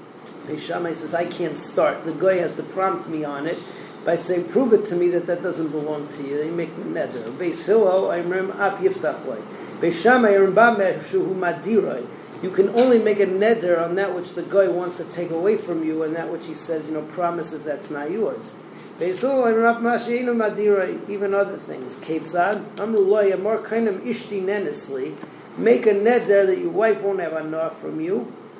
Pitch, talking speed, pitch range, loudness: 190 Hz, 205 wpm, 165-210 Hz, -22 LUFS